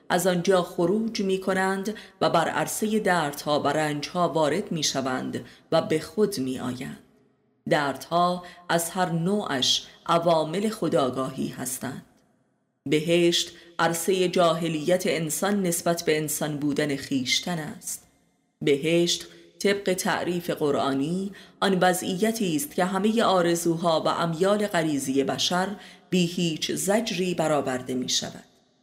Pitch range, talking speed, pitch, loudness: 150-185 Hz, 115 wpm, 170 Hz, -25 LUFS